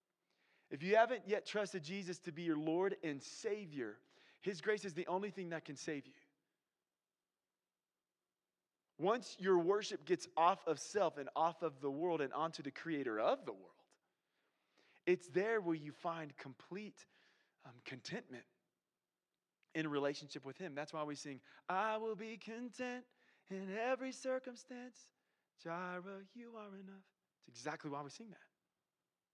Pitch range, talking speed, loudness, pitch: 155-215 Hz, 150 wpm, -41 LUFS, 180 Hz